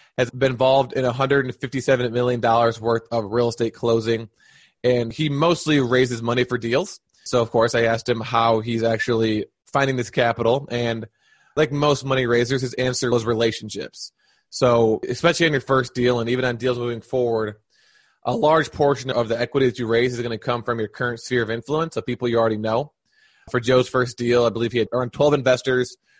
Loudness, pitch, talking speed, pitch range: -21 LUFS, 120 Hz, 200 wpm, 115-130 Hz